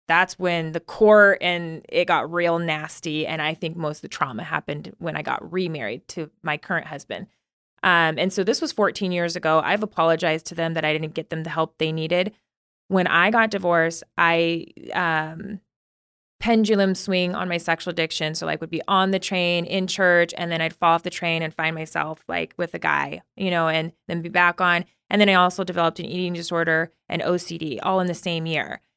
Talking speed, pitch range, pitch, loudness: 215 wpm, 160-185 Hz, 170 Hz, -22 LUFS